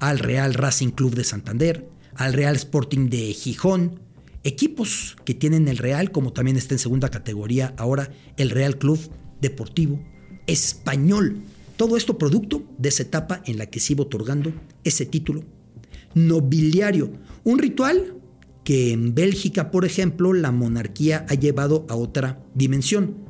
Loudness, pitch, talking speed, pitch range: -22 LUFS, 145 Hz, 145 wpm, 130-170 Hz